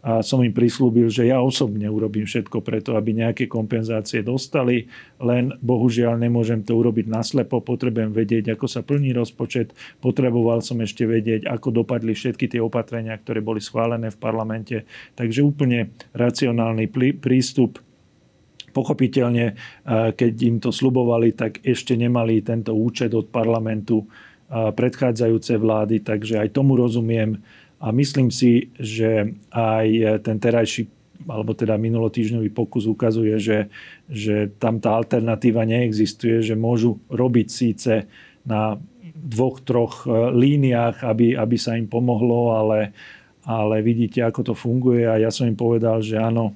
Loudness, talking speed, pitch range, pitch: -21 LUFS, 135 wpm, 110-125 Hz, 115 Hz